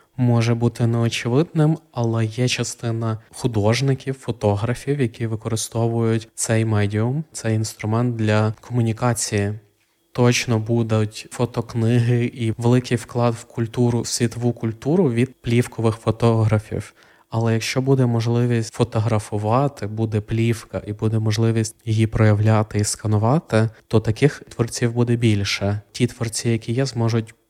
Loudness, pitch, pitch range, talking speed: -21 LUFS, 115 Hz, 110-120 Hz, 120 wpm